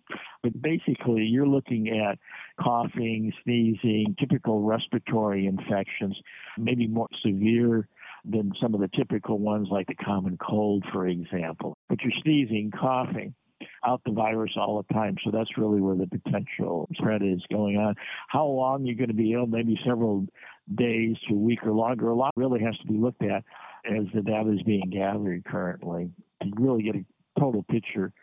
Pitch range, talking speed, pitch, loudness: 105-120 Hz, 170 wpm, 110 Hz, -27 LUFS